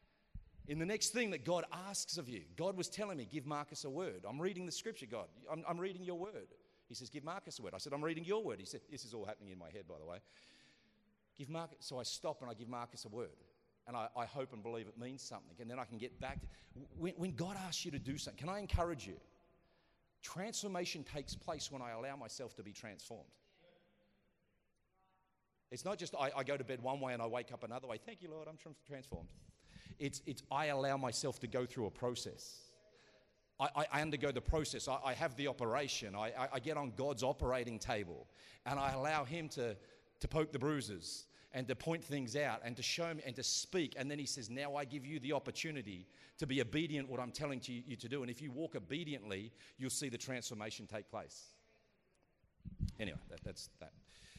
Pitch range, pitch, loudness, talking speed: 125-160 Hz, 140 Hz, -43 LUFS, 225 wpm